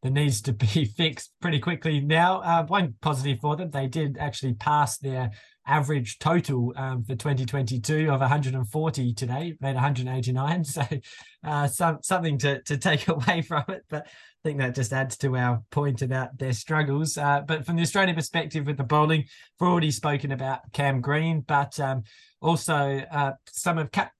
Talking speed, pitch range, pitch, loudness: 180 wpm, 135-160 Hz, 145 Hz, -26 LUFS